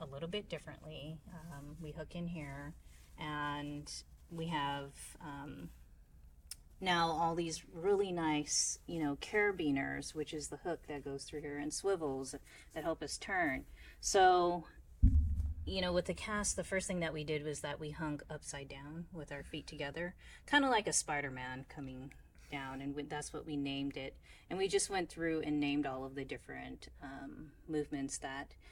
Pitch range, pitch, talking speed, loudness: 140-165 Hz, 150 Hz, 180 wpm, -38 LUFS